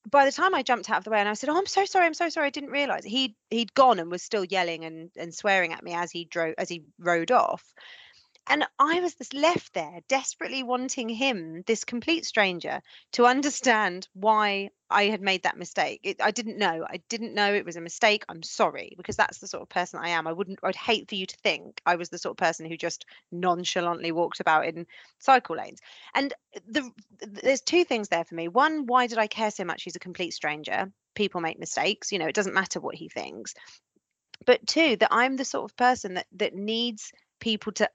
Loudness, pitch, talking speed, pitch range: -26 LUFS, 210 Hz, 230 wpm, 180-255 Hz